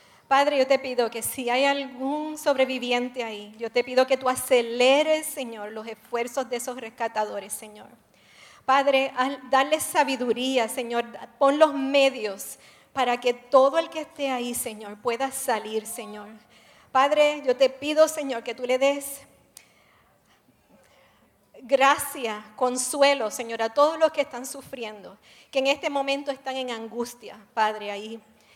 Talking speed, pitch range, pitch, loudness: 145 wpm, 230-275 Hz, 255 Hz, -24 LUFS